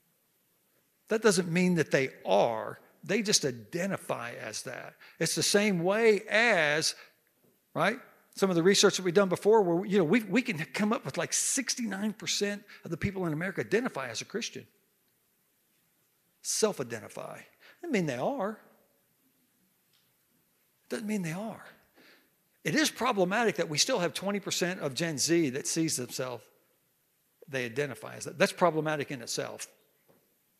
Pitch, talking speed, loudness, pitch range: 195 Hz, 155 wpm, -29 LUFS, 165-215 Hz